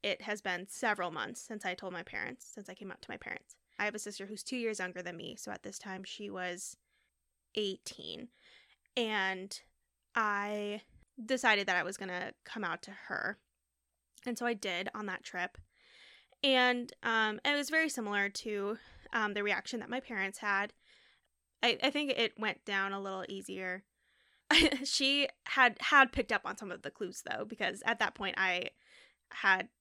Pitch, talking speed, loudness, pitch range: 210 Hz, 185 wpm, -34 LUFS, 190-240 Hz